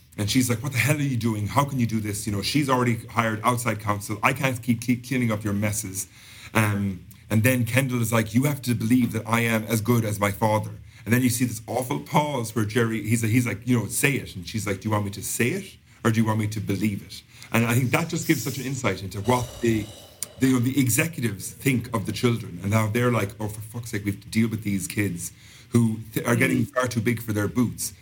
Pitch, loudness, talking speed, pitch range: 115 Hz, -24 LUFS, 270 wpm, 105-125 Hz